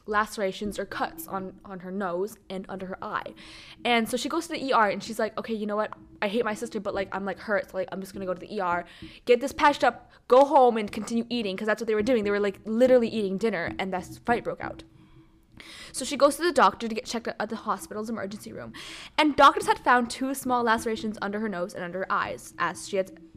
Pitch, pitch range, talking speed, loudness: 215 Hz, 195-240 Hz, 260 wpm, -26 LUFS